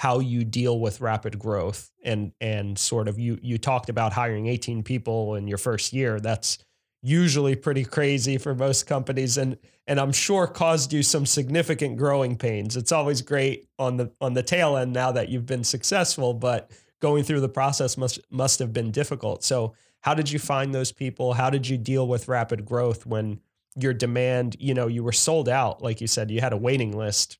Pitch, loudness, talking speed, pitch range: 125 Hz, -25 LUFS, 205 wpm, 115-135 Hz